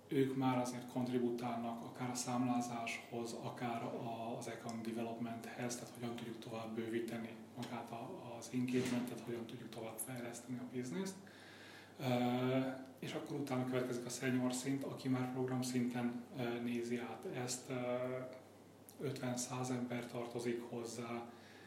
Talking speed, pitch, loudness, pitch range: 120 wpm, 120 Hz, -42 LUFS, 115-125 Hz